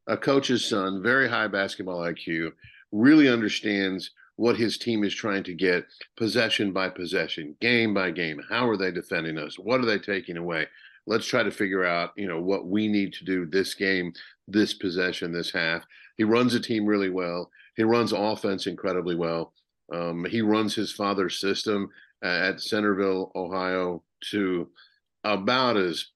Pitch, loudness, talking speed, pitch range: 95 Hz, -26 LUFS, 165 wpm, 90-110 Hz